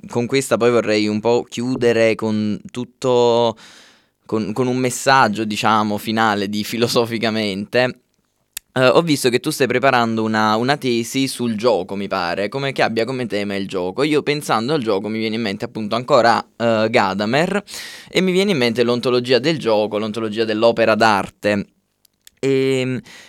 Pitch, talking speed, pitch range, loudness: 115 Hz, 160 wpm, 110-125 Hz, -18 LUFS